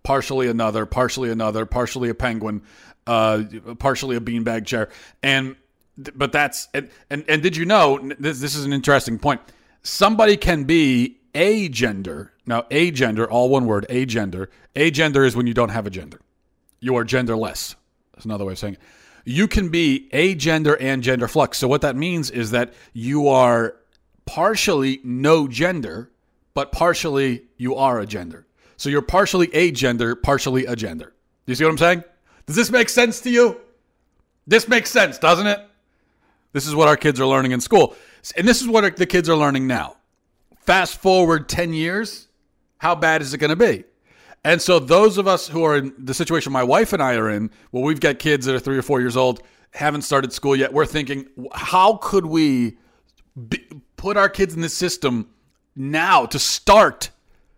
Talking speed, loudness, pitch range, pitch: 190 wpm, -19 LUFS, 125-170 Hz, 140 Hz